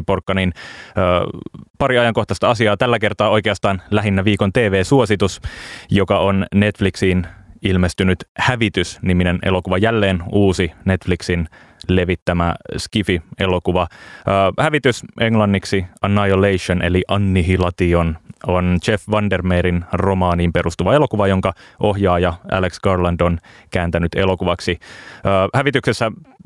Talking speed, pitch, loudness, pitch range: 100 wpm, 95 Hz, -17 LUFS, 90-105 Hz